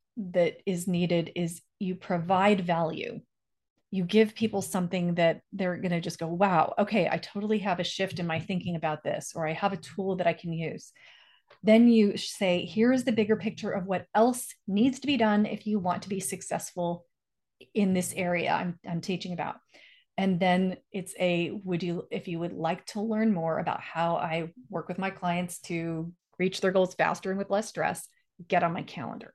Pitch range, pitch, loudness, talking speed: 175-205 Hz, 185 Hz, -29 LUFS, 200 wpm